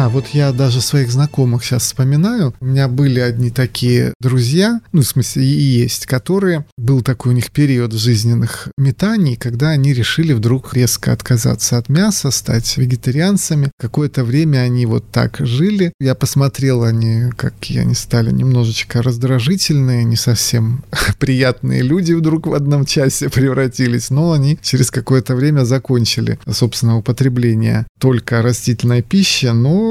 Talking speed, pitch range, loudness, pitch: 150 wpm, 120-145 Hz, -14 LUFS, 130 Hz